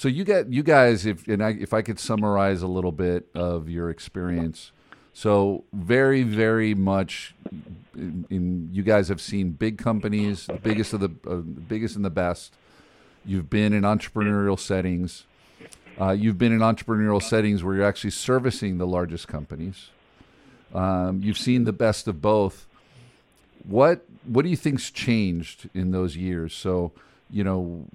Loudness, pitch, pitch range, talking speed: -24 LUFS, 100 Hz, 90-110 Hz, 165 wpm